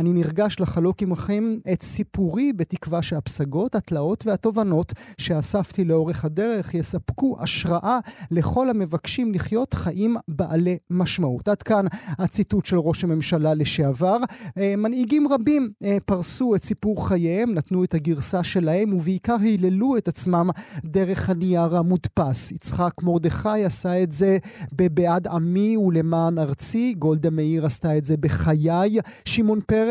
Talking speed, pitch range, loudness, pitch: 125 wpm, 165-210 Hz, -22 LUFS, 180 Hz